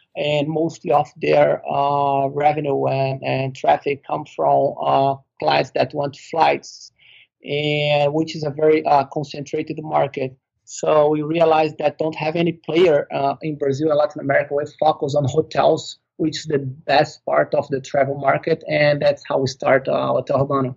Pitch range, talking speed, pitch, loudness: 135-155 Hz, 170 wpm, 145 Hz, -19 LUFS